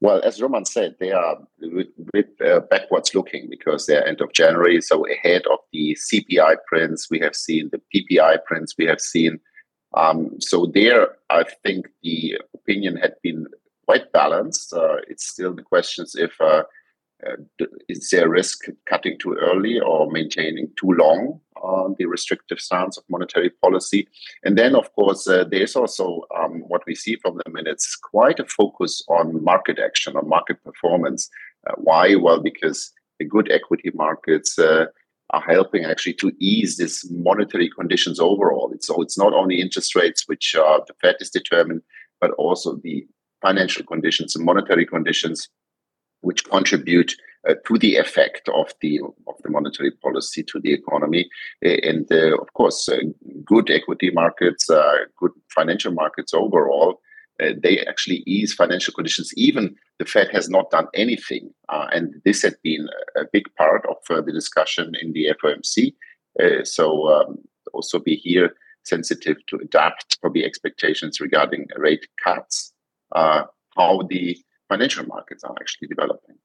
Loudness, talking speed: -19 LUFS, 160 wpm